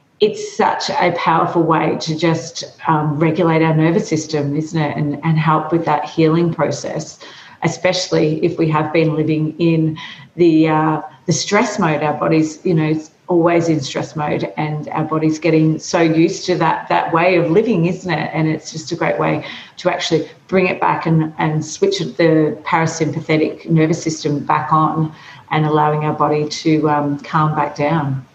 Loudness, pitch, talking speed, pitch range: -17 LUFS, 160 Hz, 180 wpm, 155-170 Hz